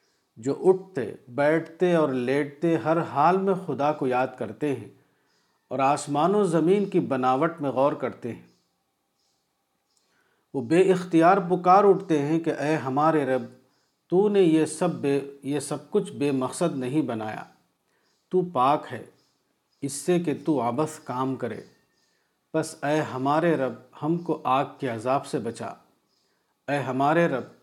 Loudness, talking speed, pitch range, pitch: -25 LUFS, 150 wpm, 135-170 Hz, 150 Hz